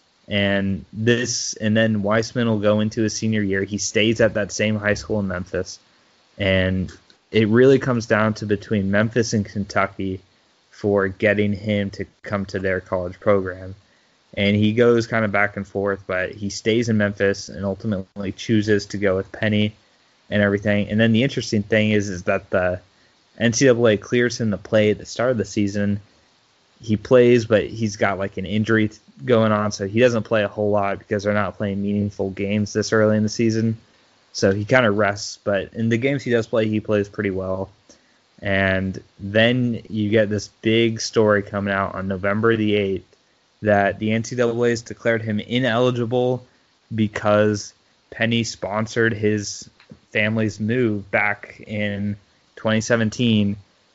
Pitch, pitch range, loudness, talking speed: 105 Hz, 100-115 Hz, -21 LUFS, 170 wpm